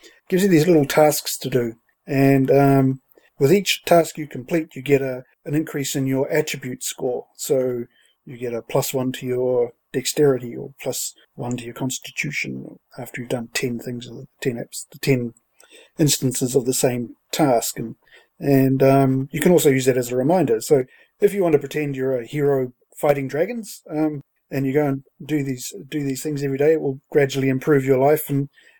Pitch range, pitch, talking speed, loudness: 130-150 Hz, 135 Hz, 195 wpm, -21 LUFS